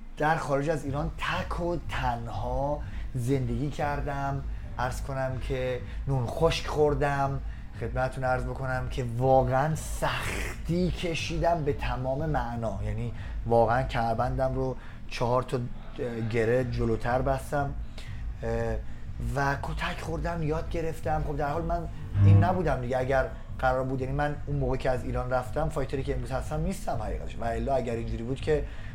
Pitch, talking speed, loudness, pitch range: 130 Hz, 145 wpm, -29 LUFS, 120-145 Hz